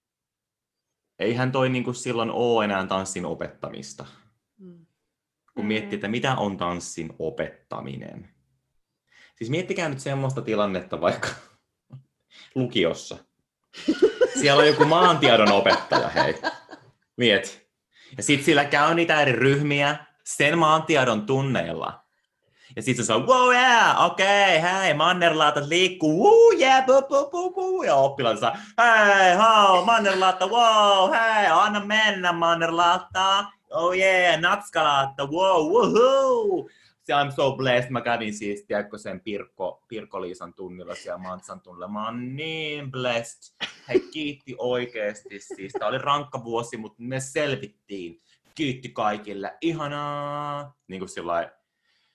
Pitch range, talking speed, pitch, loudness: 120-190 Hz, 125 wpm, 145 Hz, -21 LUFS